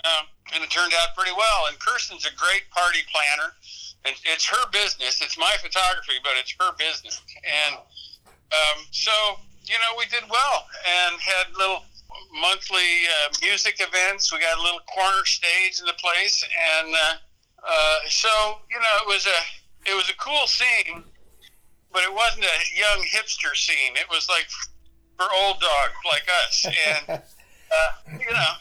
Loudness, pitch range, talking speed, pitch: -21 LUFS, 160-215 Hz, 170 wpm, 185 Hz